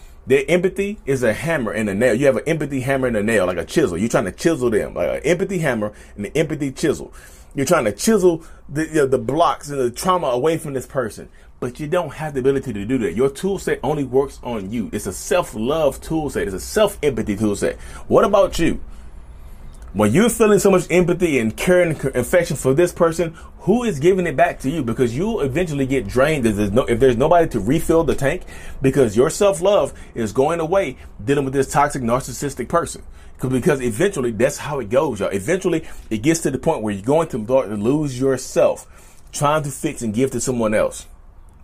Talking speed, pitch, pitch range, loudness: 220 wpm, 135 Hz, 120-170 Hz, -19 LUFS